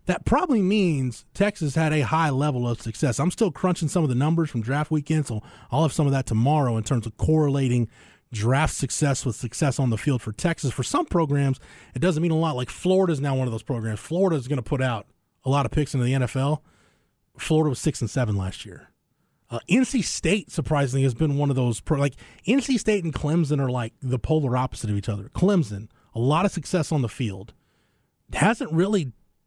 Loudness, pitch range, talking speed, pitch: -24 LUFS, 120-160 Hz, 225 wpm, 140 Hz